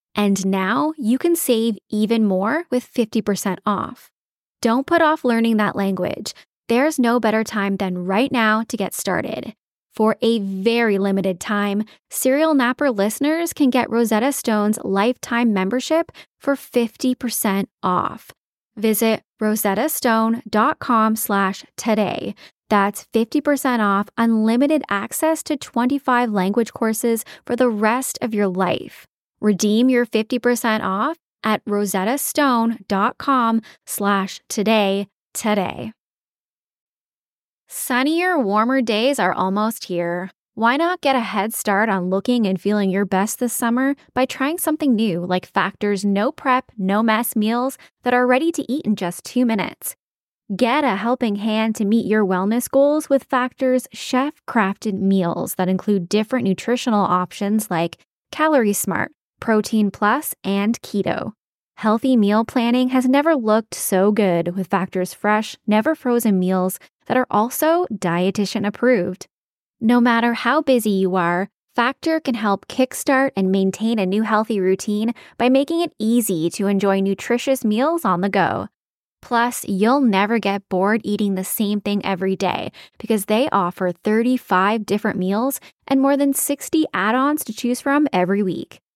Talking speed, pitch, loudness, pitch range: 140 wpm, 220 Hz, -19 LUFS, 200-255 Hz